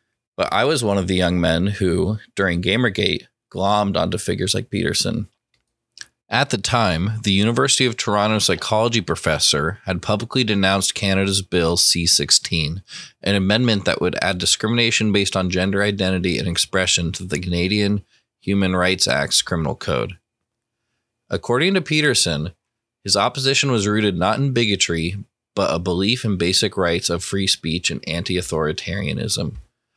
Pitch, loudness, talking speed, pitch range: 100 Hz, -19 LUFS, 150 wpm, 90-110 Hz